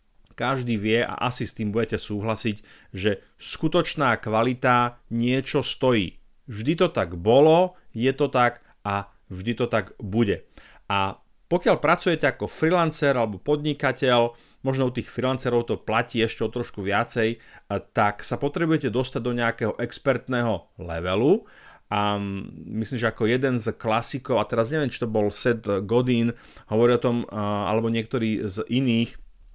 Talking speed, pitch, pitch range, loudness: 145 wpm, 120 Hz, 110-130 Hz, -24 LUFS